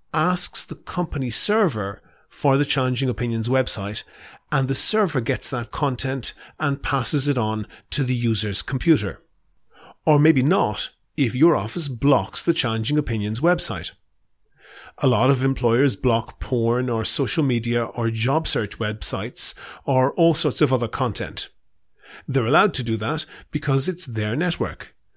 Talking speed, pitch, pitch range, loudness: 150 wpm, 130 Hz, 115-150 Hz, -21 LUFS